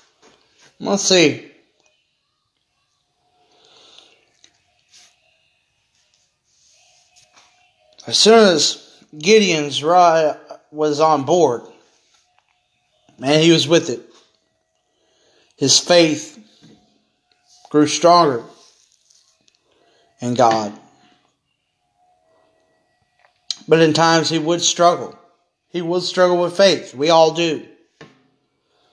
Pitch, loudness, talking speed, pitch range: 165 Hz, -15 LUFS, 75 wpm, 150-180 Hz